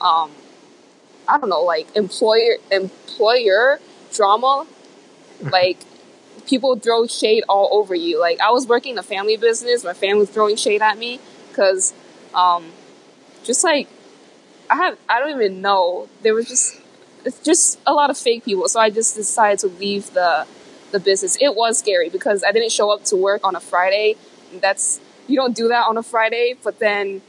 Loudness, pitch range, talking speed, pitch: -17 LUFS, 195-250 Hz, 180 wpm, 215 Hz